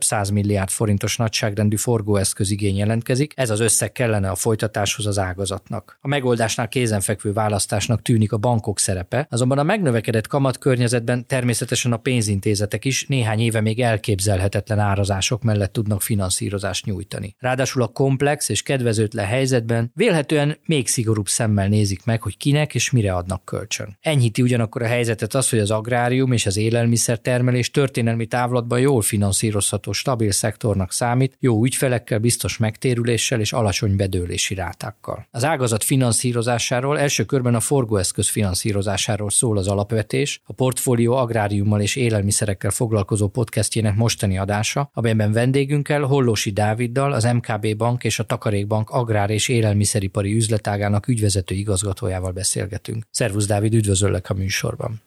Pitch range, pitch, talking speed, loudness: 105-125 Hz, 115 Hz, 135 wpm, -20 LUFS